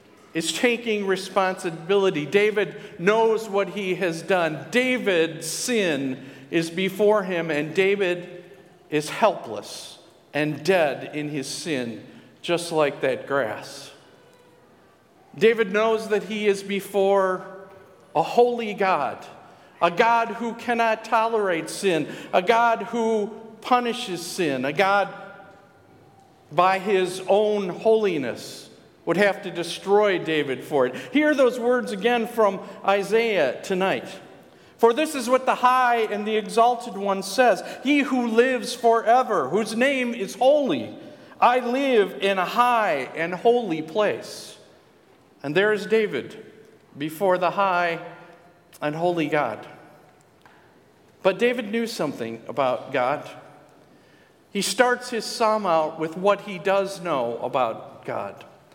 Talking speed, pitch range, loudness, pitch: 125 wpm, 175-230 Hz, -23 LUFS, 200 Hz